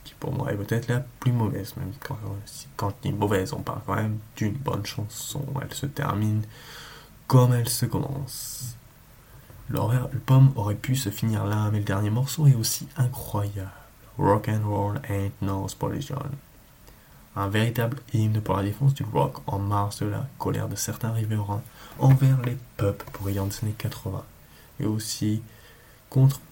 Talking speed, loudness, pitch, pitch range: 170 wpm, -26 LUFS, 115 Hz, 105-130 Hz